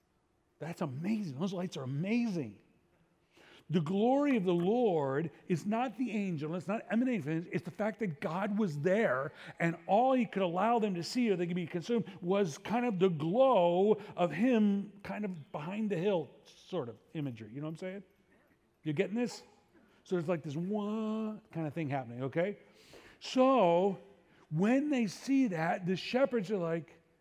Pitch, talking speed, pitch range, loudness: 190 Hz, 180 wpm, 165-220 Hz, -33 LUFS